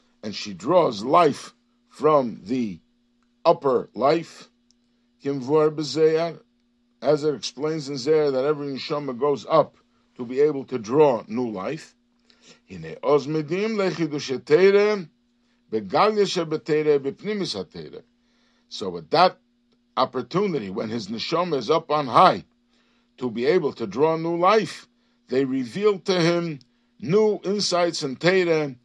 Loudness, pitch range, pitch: -23 LUFS, 135-210 Hz, 160 Hz